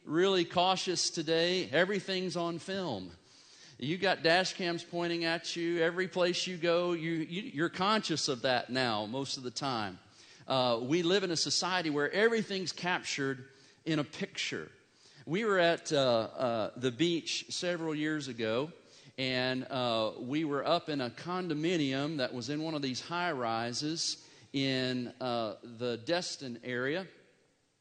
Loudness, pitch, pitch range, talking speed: -32 LUFS, 155 Hz, 130-175 Hz, 155 wpm